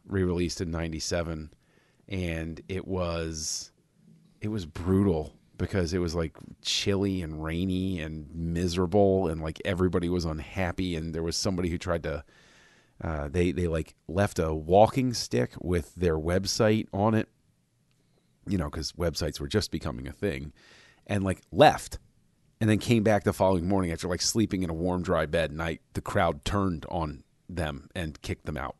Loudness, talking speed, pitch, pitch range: -28 LUFS, 165 wpm, 90 Hz, 80-95 Hz